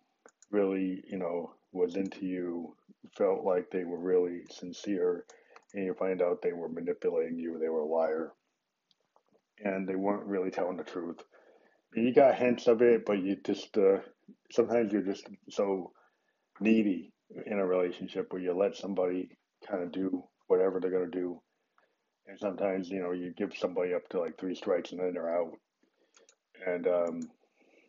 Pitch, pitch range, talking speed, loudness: 95 Hz, 90-105 Hz, 170 wpm, -32 LUFS